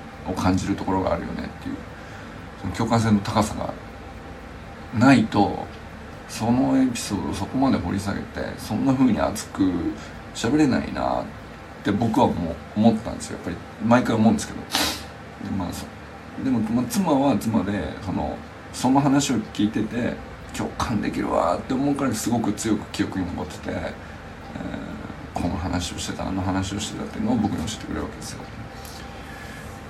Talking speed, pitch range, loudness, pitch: 290 characters per minute, 95-120 Hz, -24 LUFS, 105 Hz